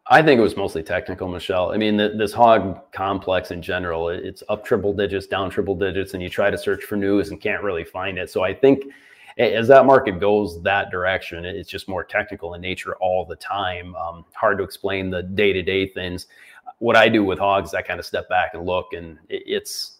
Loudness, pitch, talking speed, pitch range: -21 LUFS, 95 Hz, 225 wpm, 90-105 Hz